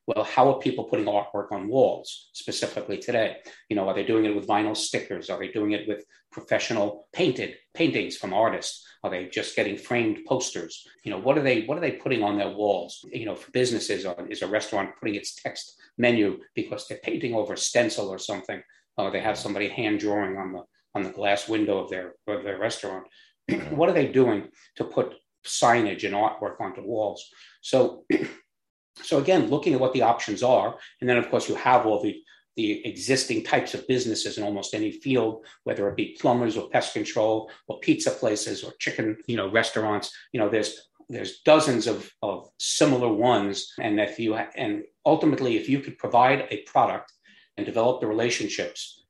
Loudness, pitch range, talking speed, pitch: -26 LUFS, 100-135 Hz, 195 wpm, 110 Hz